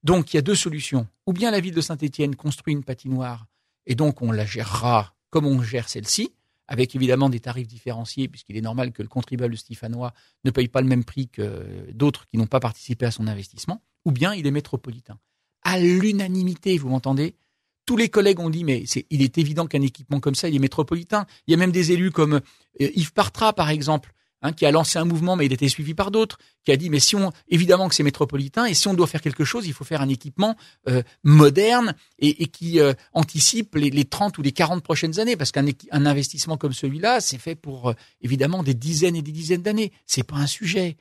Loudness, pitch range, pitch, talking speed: -22 LUFS, 130-170 Hz, 145 Hz, 235 wpm